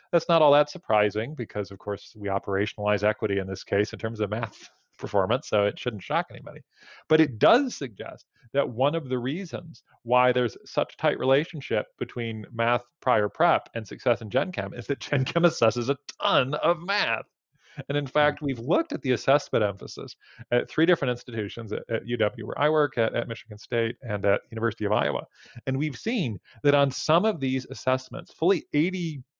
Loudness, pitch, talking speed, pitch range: -26 LUFS, 125 Hz, 195 wpm, 110-150 Hz